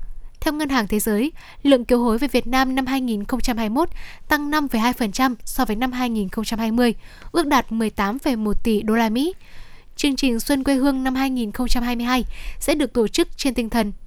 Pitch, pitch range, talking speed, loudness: 250 Hz, 225-275 Hz, 170 wpm, -21 LUFS